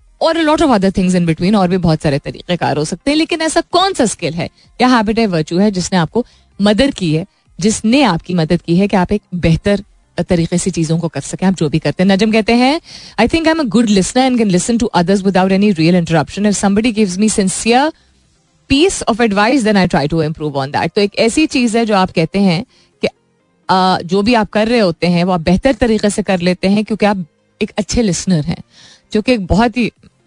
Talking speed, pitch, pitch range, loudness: 230 wpm, 200 Hz, 175-230 Hz, -14 LUFS